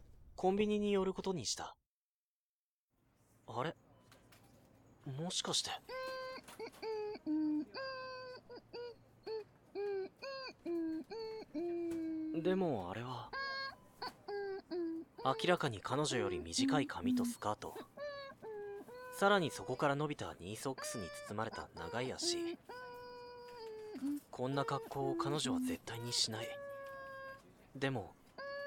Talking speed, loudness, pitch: 170 characters per minute, -40 LUFS, 275 Hz